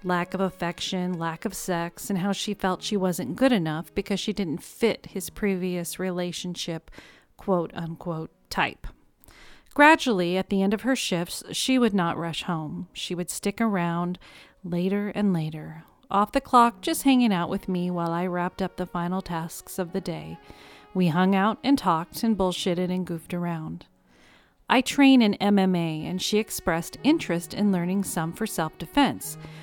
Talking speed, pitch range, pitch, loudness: 170 wpm, 170-205 Hz, 185 Hz, -25 LUFS